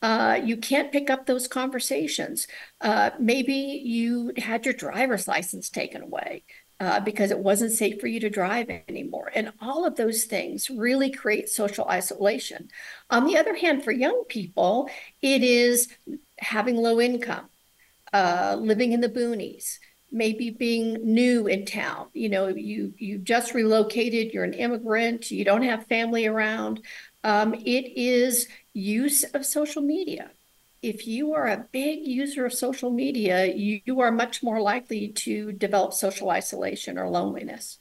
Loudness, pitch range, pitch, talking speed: -25 LUFS, 215-260 Hz, 235 Hz, 155 wpm